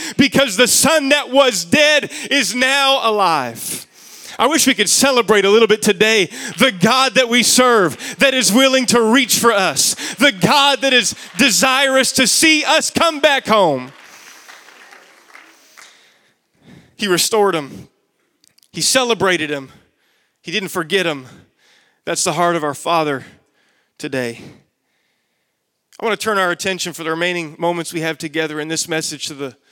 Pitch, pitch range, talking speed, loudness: 225 Hz, 170-265 Hz, 155 wpm, -14 LUFS